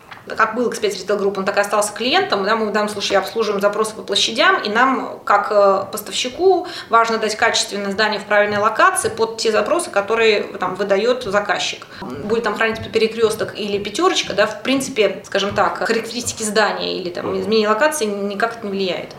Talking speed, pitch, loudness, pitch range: 180 wpm, 215 Hz, -18 LUFS, 200-230 Hz